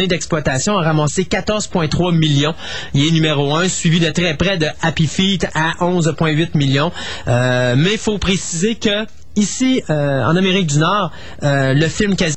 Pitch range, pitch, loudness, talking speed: 150-190 Hz, 165 Hz, -16 LUFS, 170 wpm